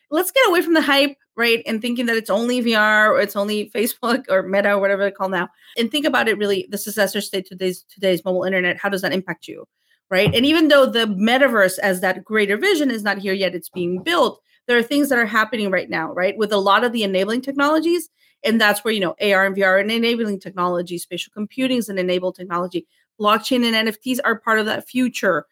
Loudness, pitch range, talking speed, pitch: -19 LUFS, 190-240 Hz, 235 wpm, 210 Hz